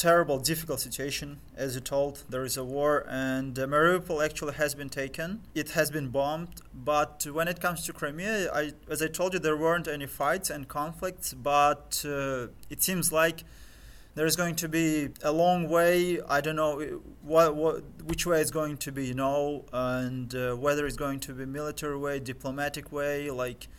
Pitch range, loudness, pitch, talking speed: 135-160 Hz, -29 LUFS, 150 Hz, 190 wpm